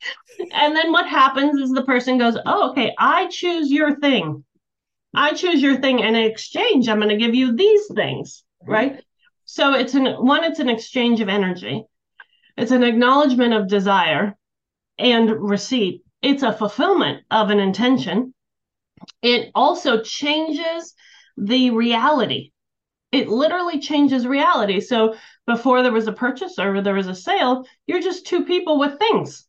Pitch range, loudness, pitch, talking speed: 225-310 Hz, -18 LUFS, 260 Hz, 155 wpm